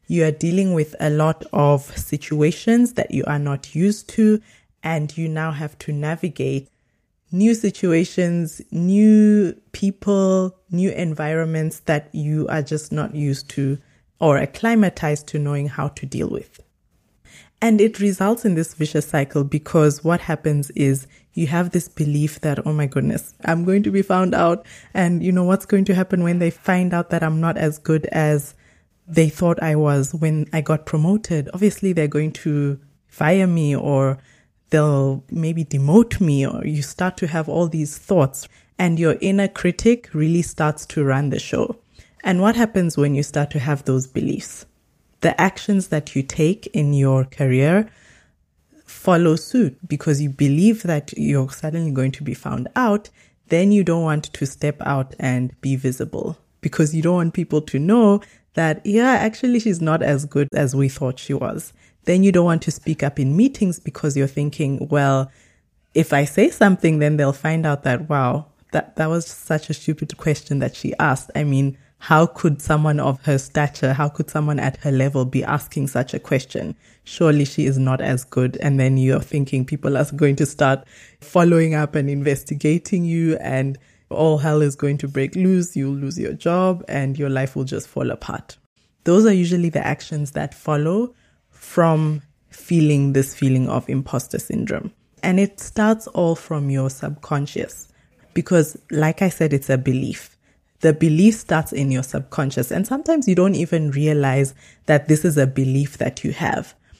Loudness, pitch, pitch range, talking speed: -20 LUFS, 155 Hz, 140-175 Hz, 180 wpm